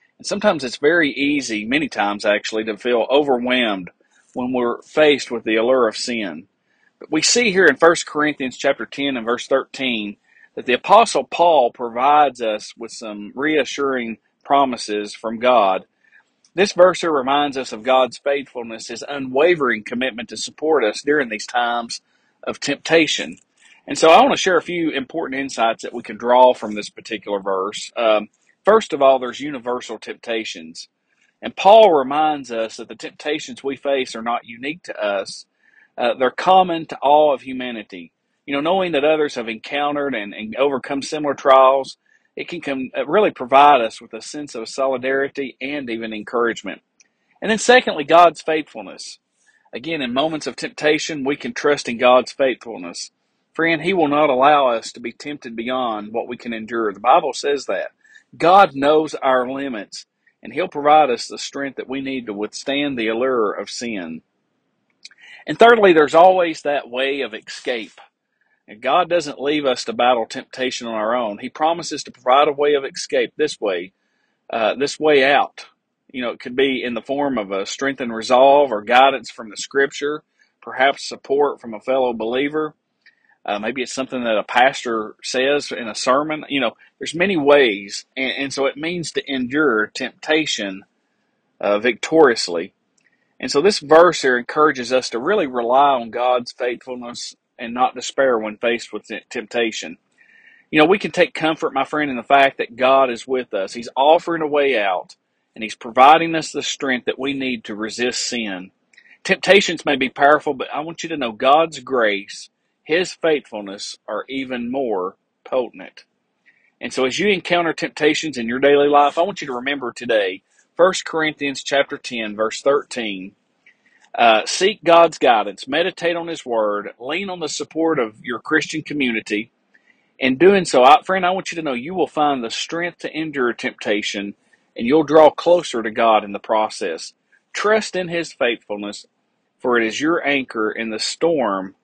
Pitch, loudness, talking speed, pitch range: 135 Hz, -18 LUFS, 175 wpm, 120-155 Hz